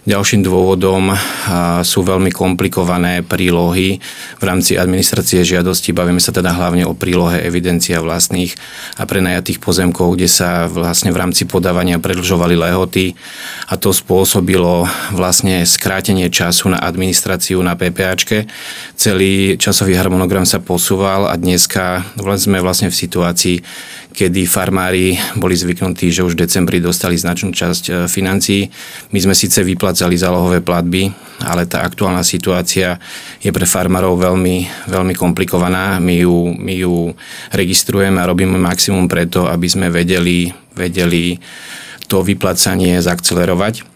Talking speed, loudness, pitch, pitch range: 130 wpm, -13 LUFS, 90 Hz, 90-95 Hz